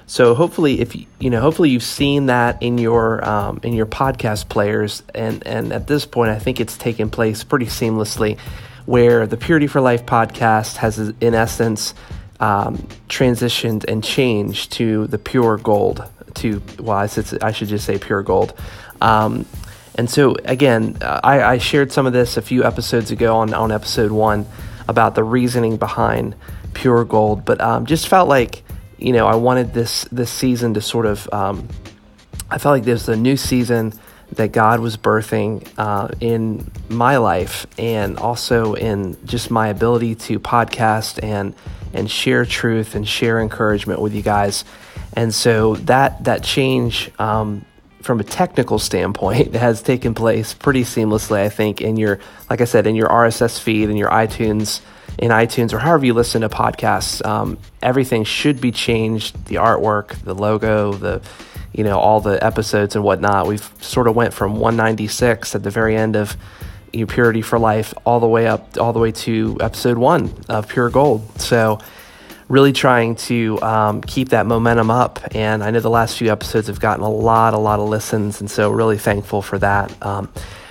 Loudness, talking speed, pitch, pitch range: -17 LUFS, 180 wpm, 110 Hz, 105-120 Hz